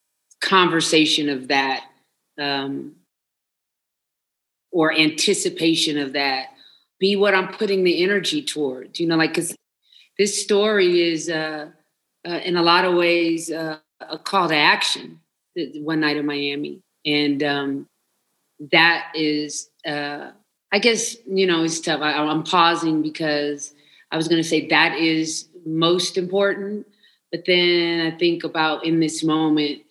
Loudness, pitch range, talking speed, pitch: -20 LUFS, 150-175 Hz, 140 wpm, 160 Hz